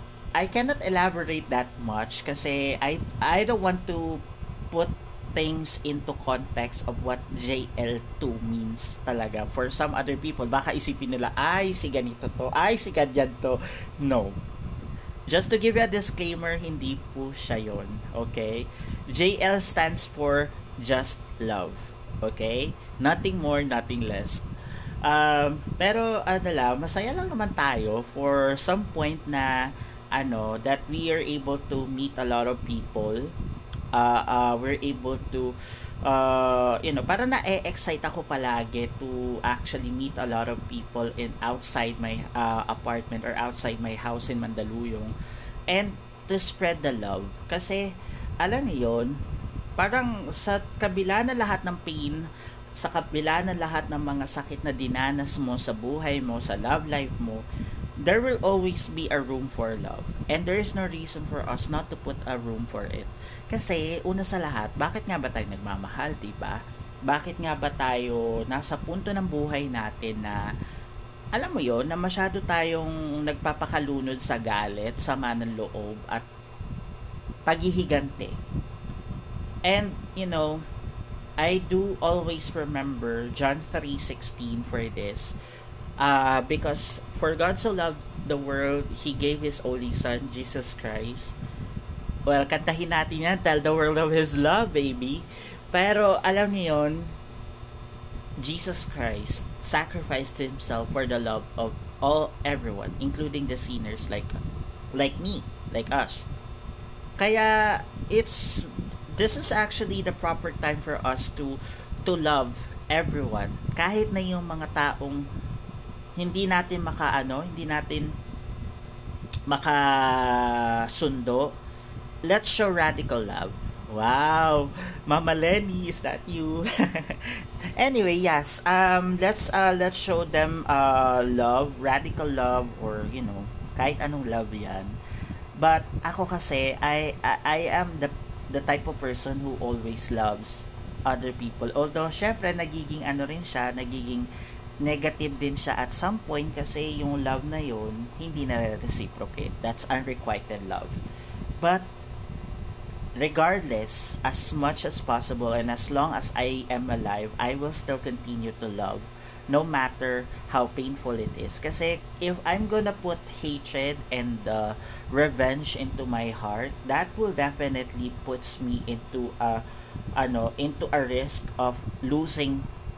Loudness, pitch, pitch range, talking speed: -28 LUFS, 135 Hz, 120-155 Hz, 140 wpm